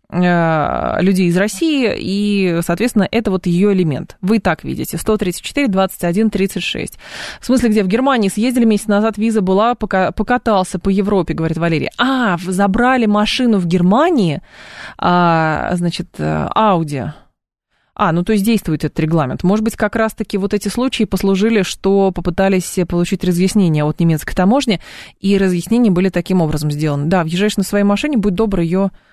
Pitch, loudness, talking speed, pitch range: 195 Hz, -15 LUFS, 155 wpm, 175-215 Hz